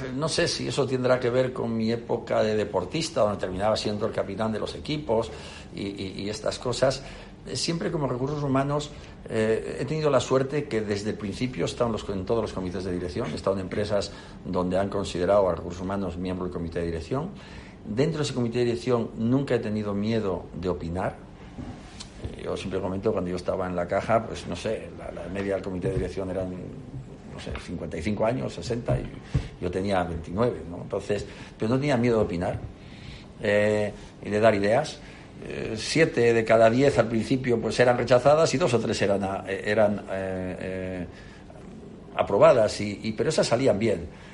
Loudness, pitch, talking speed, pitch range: -26 LUFS, 105 Hz, 190 wpm, 95-125 Hz